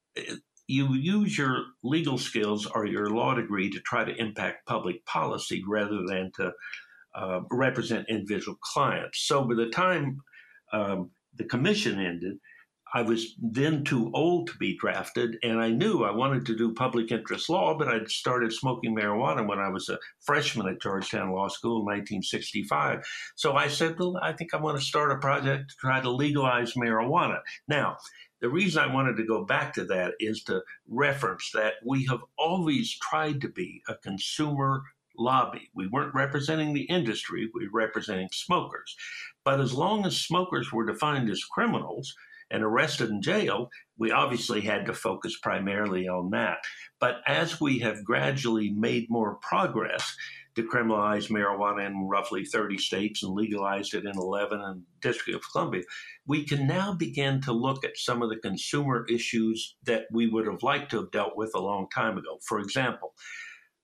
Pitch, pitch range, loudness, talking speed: 120 Hz, 105-140 Hz, -28 LUFS, 175 wpm